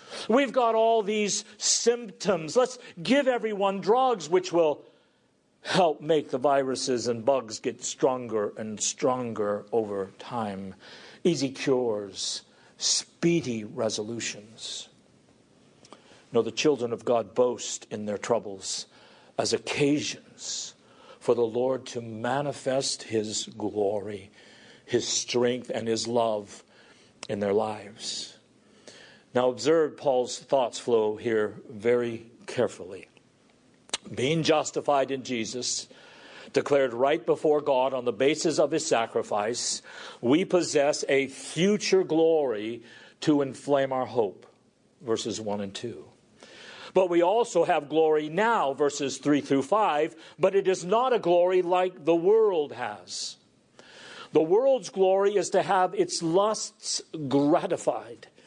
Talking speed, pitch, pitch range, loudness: 120 wpm, 140 Hz, 120-185 Hz, -26 LUFS